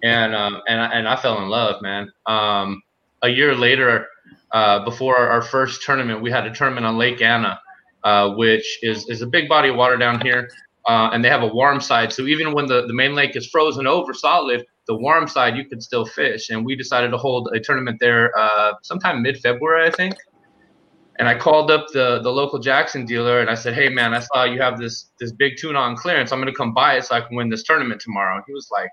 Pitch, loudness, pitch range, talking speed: 120 Hz, -18 LUFS, 115-135 Hz, 245 wpm